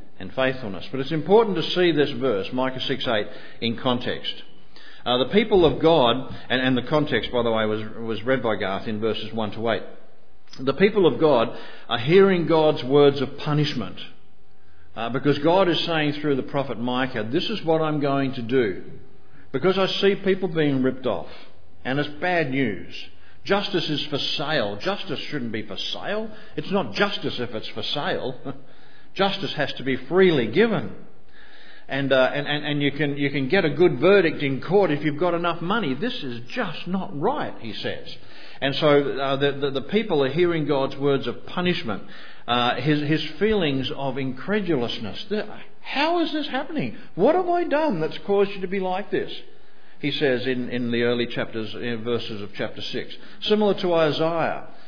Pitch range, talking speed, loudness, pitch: 125-180 Hz, 185 wpm, -23 LUFS, 145 Hz